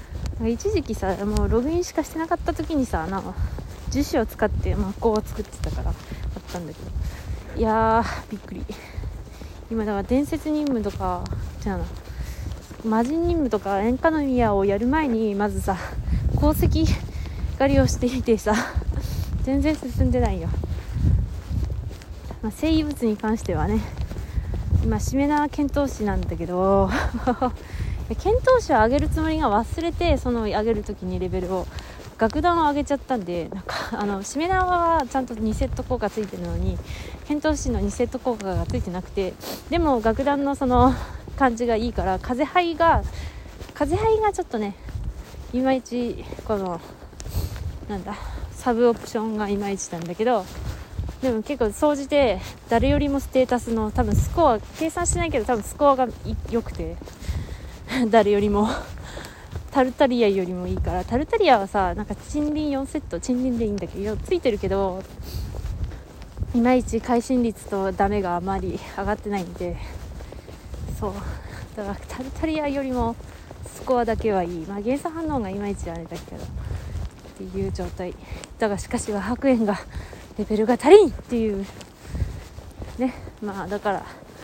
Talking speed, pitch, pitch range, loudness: 300 characters per minute, 225 Hz, 185-275 Hz, -24 LUFS